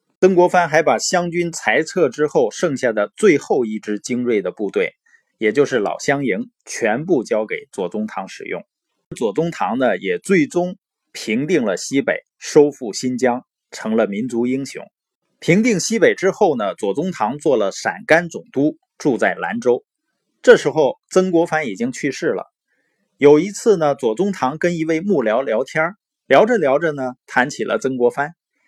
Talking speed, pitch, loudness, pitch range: 245 characters per minute, 165 Hz, -18 LUFS, 135-210 Hz